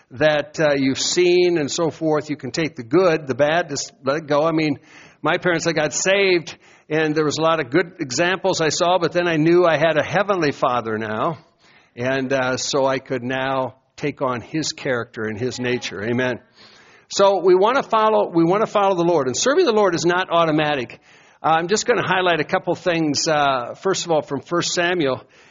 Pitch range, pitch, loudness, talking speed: 135-175 Hz, 155 Hz, -19 LUFS, 215 wpm